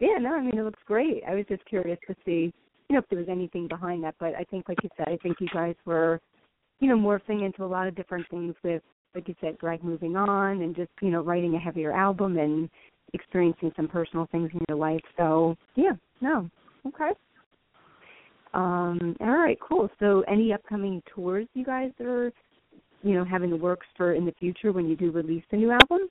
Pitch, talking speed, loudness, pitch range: 180 Hz, 220 wpm, -27 LUFS, 170-205 Hz